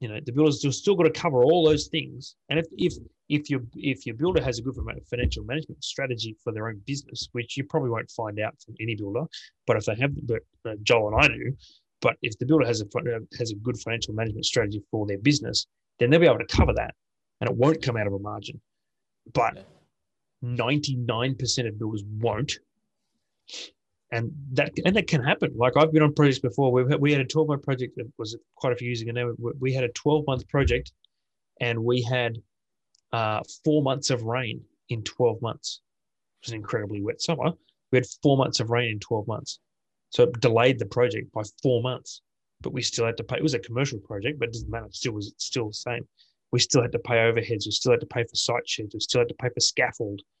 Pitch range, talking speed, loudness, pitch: 115-140 Hz, 230 wpm, -26 LUFS, 125 Hz